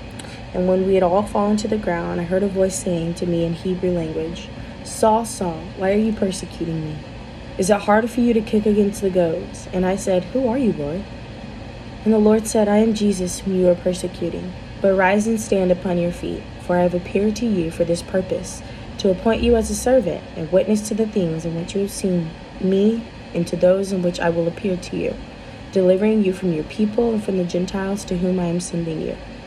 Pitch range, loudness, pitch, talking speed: 170-210 Hz, -20 LUFS, 185 Hz, 230 wpm